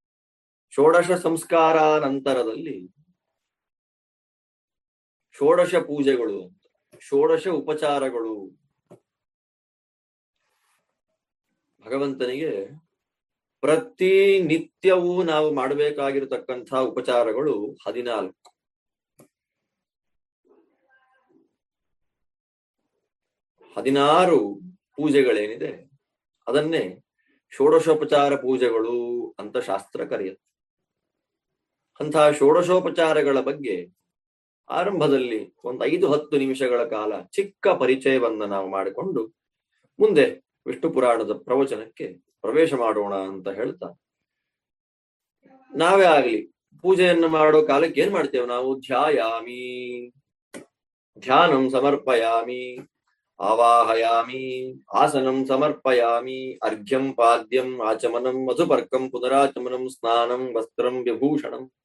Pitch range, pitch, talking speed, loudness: 120-165 Hz, 135 Hz, 60 wpm, -22 LUFS